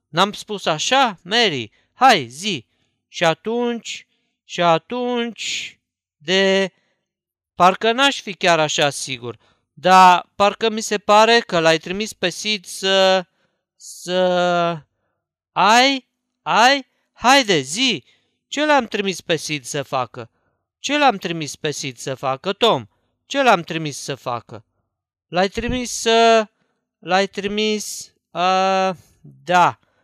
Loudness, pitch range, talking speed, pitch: -18 LUFS, 145-225 Hz, 120 wpm, 185 Hz